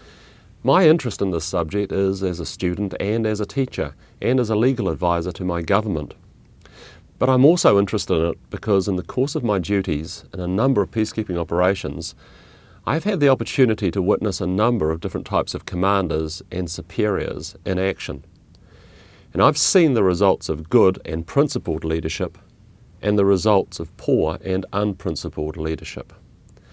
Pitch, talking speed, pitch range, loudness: 95 Hz, 170 wpm, 85-105 Hz, -21 LUFS